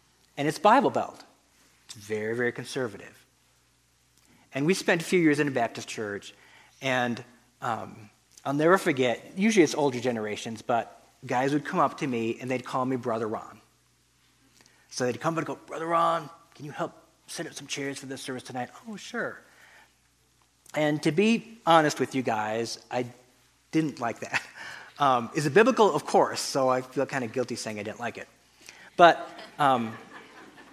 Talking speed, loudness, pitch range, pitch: 180 wpm, -27 LUFS, 120-155 Hz, 130 Hz